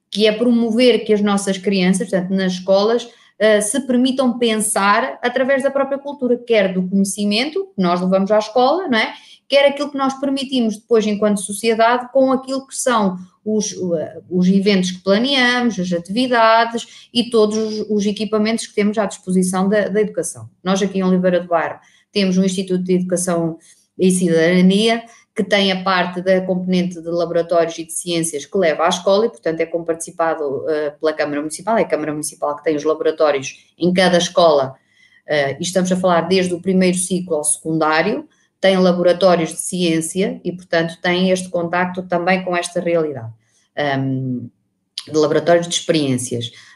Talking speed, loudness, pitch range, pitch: 165 wpm, -17 LUFS, 170-215 Hz, 185 Hz